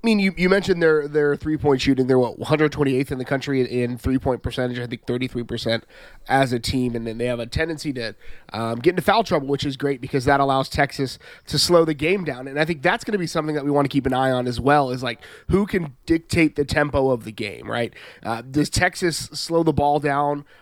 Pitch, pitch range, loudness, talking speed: 140 Hz, 125-155 Hz, -21 LUFS, 245 wpm